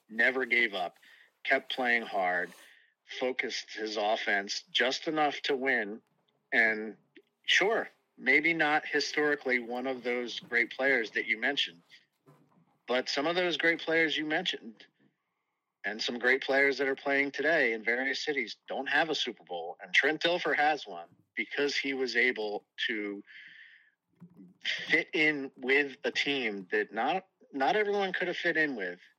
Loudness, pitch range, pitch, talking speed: -29 LUFS, 125-155 Hz, 140 Hz, 150 wpm